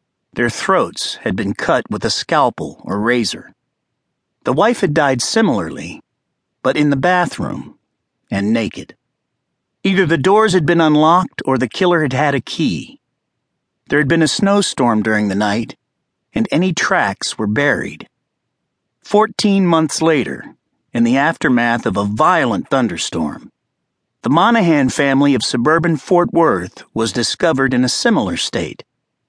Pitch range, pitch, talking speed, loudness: 125-180 Hz, 155 Hz, 145 wpm, -15 LUFS